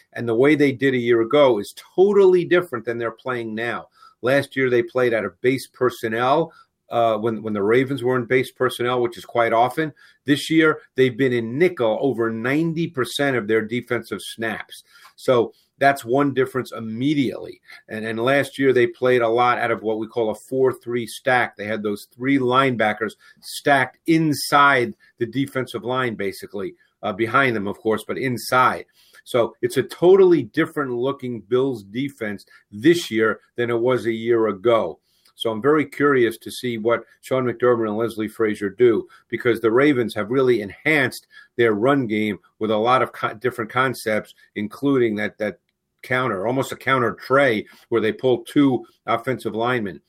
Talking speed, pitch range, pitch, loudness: 175 wpm, 115-140 Hz, 125 Hz, -21 LUFS